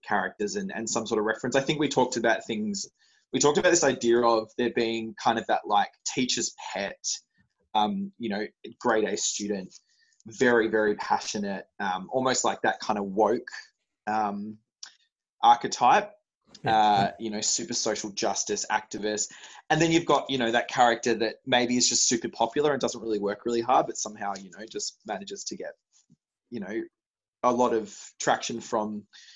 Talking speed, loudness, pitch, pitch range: 180 wpm, -26 LUFS, 120 Hz, 110-150 Hz